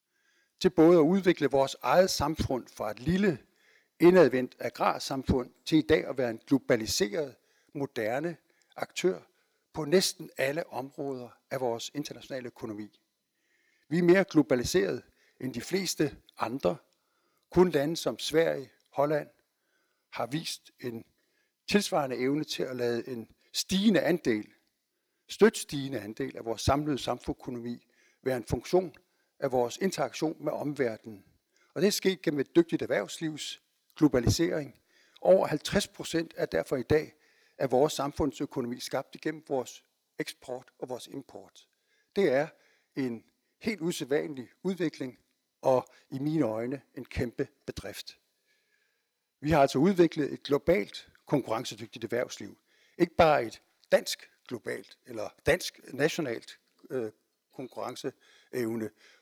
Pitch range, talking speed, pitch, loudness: 125-170 Hz, 125 wpm, 145 Hz, -29 LUFS